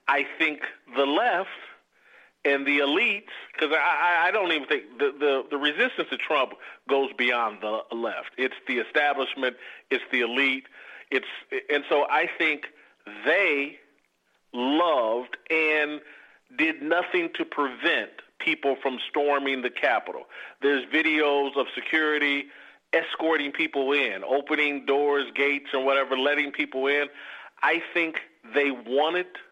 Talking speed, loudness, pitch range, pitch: 130 wpm, -25 LUFS, 140-155 Hz, 145 Hz